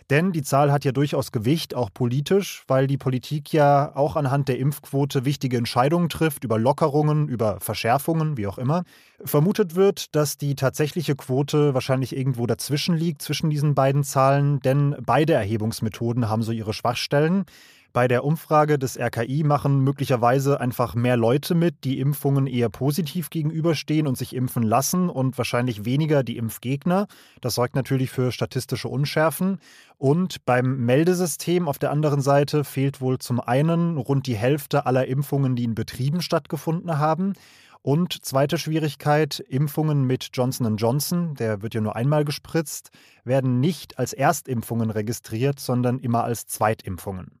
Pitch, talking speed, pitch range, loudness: 140 Hz, 155 wpm, 125-150 Hz, -23 LUFS